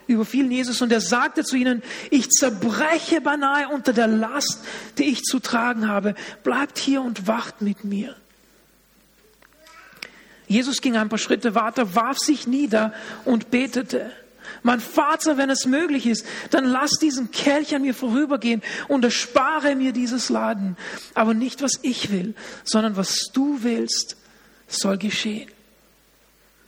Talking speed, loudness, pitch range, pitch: 145 wpm, -22 LUFS, 225-275 Hz, 250 Hz